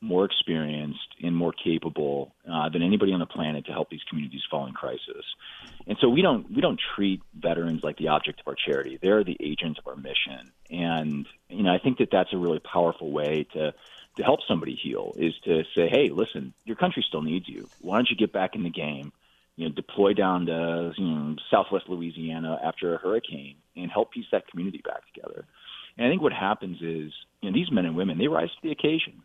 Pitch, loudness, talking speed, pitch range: 80 Hz, -27 LUFS, 220 wpm, 75-85 Hz